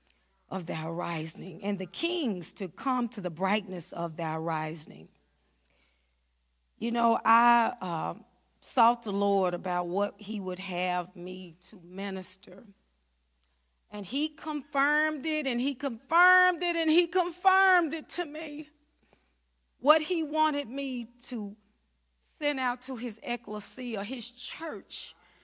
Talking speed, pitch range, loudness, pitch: 130 wpm, 180-285 Hz, -29 LUFS, 215 Hz